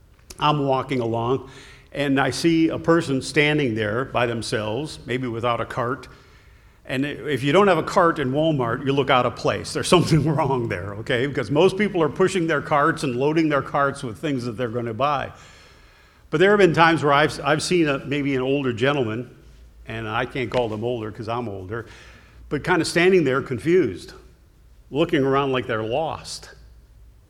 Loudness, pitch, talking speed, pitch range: -21 LUFS, 135 Hz, 190 wpm, 120-155 Hz